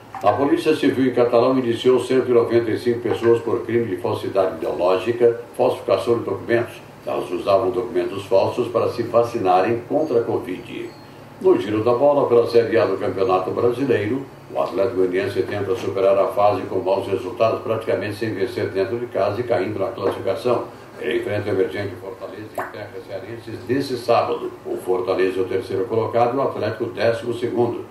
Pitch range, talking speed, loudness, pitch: 105-120 Hz, 165 wpm, -20 LUFS, 120 Hz